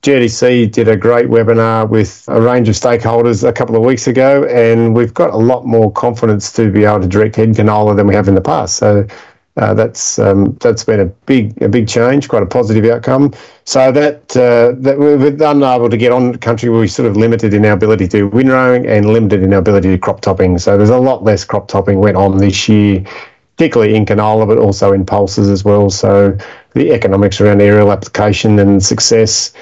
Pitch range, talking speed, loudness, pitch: 100-120 Hz, 215 wpm, -10 LUFS, 110 Hz